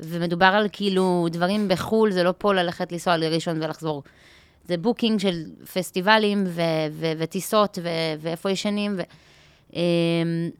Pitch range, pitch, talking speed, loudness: 165-195 Hz, 175 Hz, 110 wpm, -23 LUFS